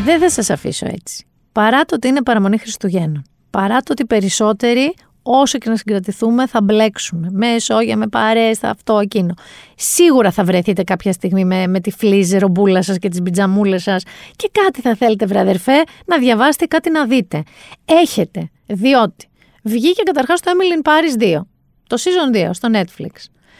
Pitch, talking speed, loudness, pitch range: 220 Hz, 170 wpm, -15 LUFS, 195-270 Hz